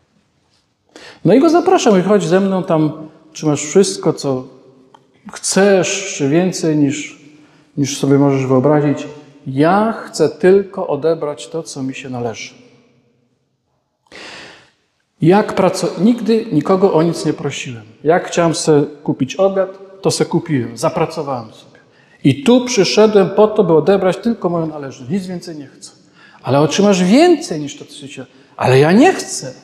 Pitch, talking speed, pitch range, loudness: 160 Hz, 150 wpm, 140-195 Hz, -14 LUFS